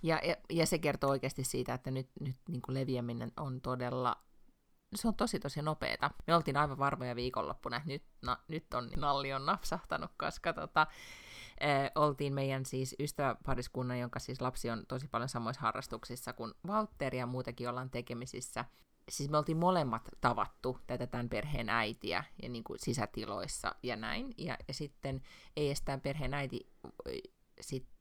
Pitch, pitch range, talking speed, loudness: 135 Hz, 125-150 Hz, 165 wpm, -37 LUFS